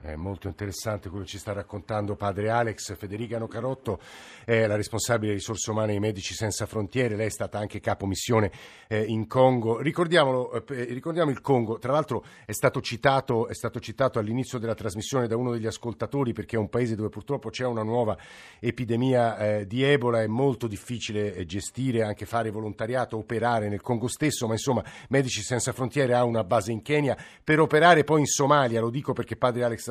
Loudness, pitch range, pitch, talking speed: -26 LUFS, 105-125 Hz, 115 Hz, 185 wpm